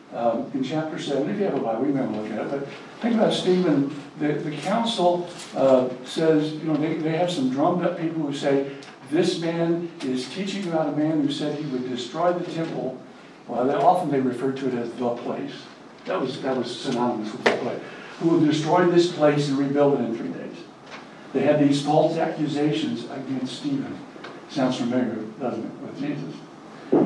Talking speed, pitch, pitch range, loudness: 200 wpm, 150 Hz, 135-170 Hz, -24 LUFS